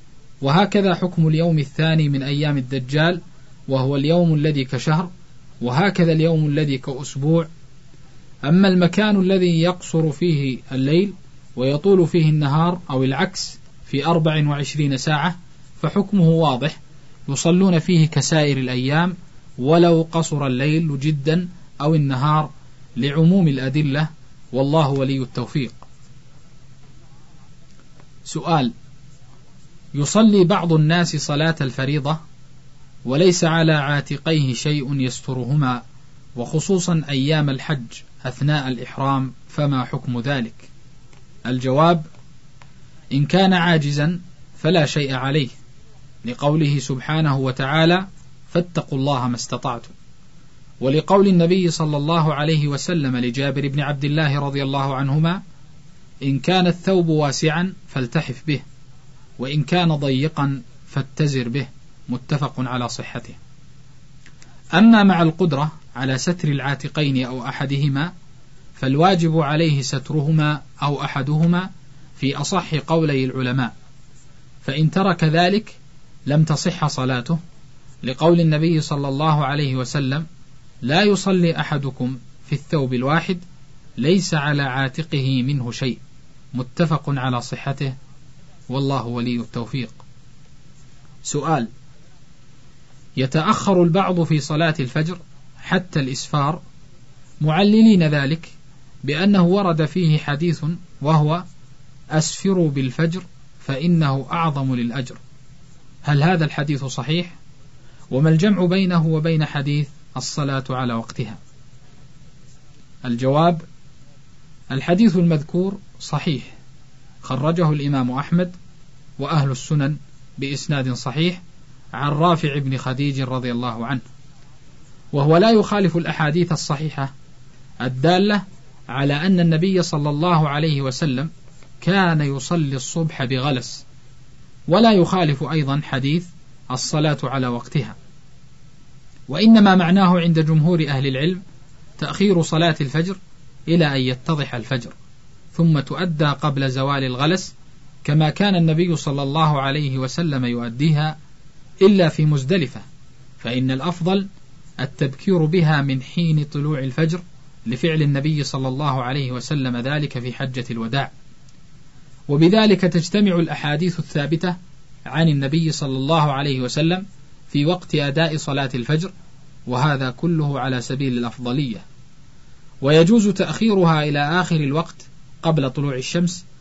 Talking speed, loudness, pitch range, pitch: 100 wpm, -19 LUFS, 135-165 Hz, 145 Hz